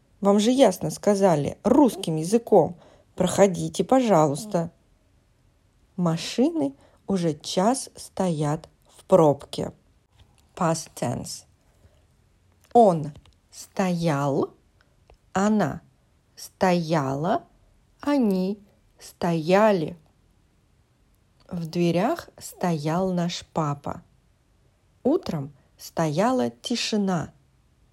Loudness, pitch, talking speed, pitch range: -24 LUFS, 180 Hz, 65 wpm, 160-205 Hz